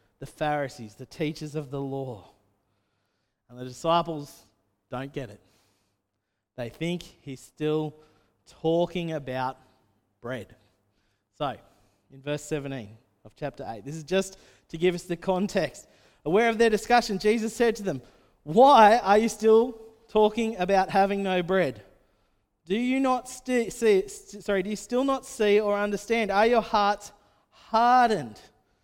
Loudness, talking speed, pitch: -25 LUFS, 145 wpm, 155 Hz